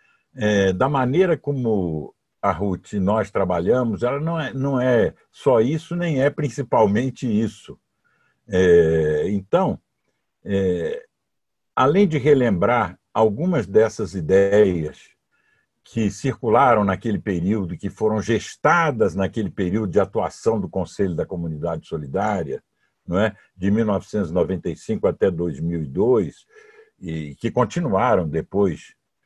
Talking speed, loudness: 115 wpm, -21 LUFS